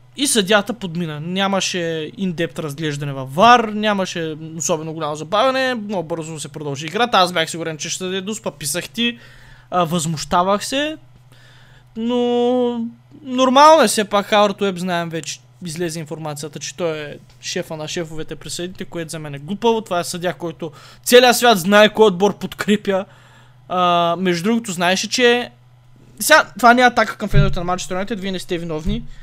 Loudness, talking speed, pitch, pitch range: -18 LUFS, 160 wpm, 180 Hz, 155-210 Hz